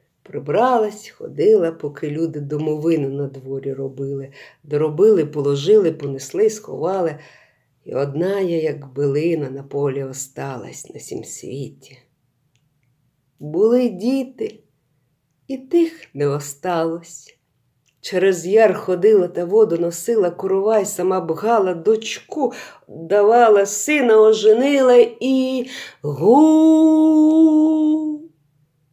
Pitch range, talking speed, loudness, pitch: 145-230 Hz, 90 wpm, -17 LUFS, 180 Hz